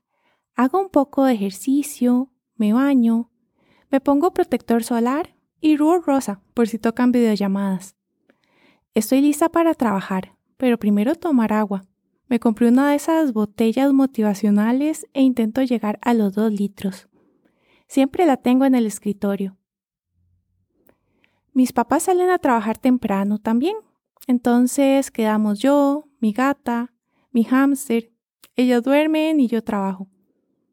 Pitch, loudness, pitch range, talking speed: 240 Hz, -19 LUFS, 215-275 Hz, 125 wpm